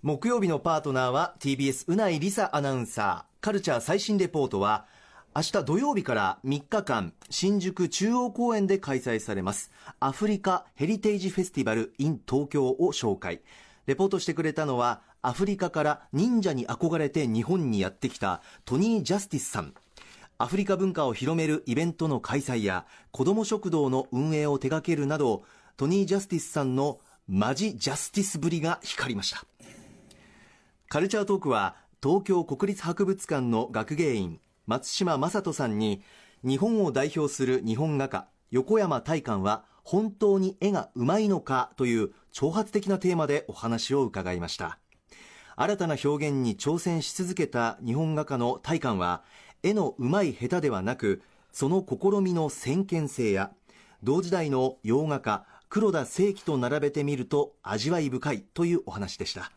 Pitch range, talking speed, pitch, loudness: 130-190 Hz, 330 characters per minute, 150 Hz, -28 LUFS